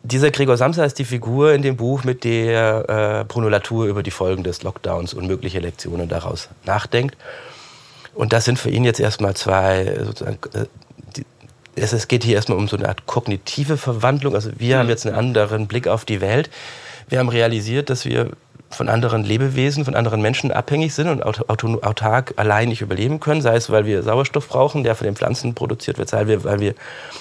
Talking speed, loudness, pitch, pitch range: 195 wpm, -19 LUFS, 115 Hz, 105-130 Hz